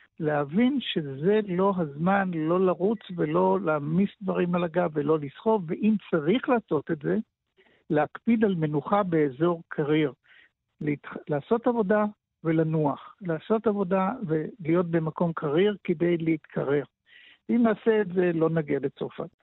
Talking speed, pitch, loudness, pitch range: 125 wpm, 180 Hz, -26 LUFS, 155-210 Hz